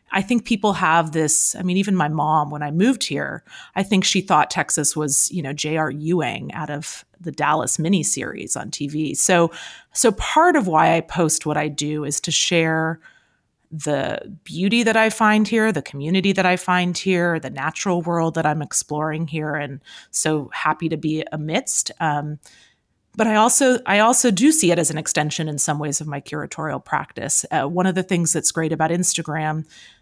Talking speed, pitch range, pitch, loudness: 195 wpm, 150-190 Hz, 160 Hz, -19 LUFS